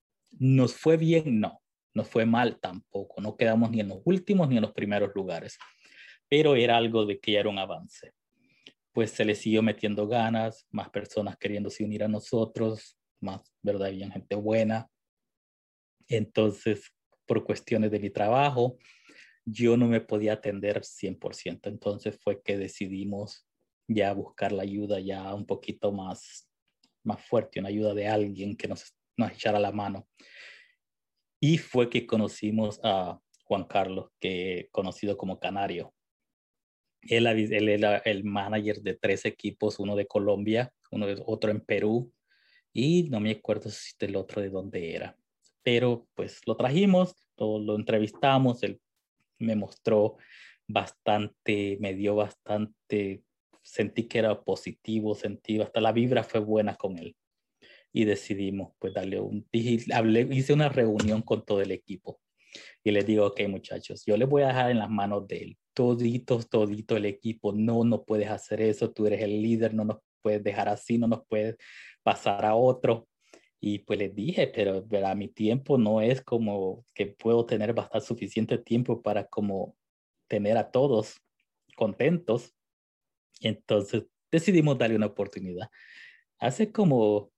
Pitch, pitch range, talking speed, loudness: 110 Hz, 100-115 Hz, 155 wpm, -28 LUFS